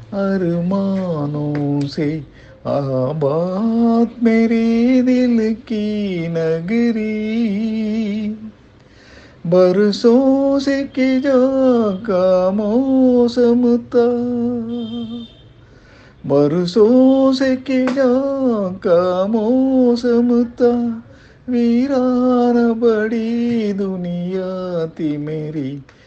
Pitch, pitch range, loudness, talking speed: 225 Hz, 180-240 Hz, -16 LUFS, 55 wpm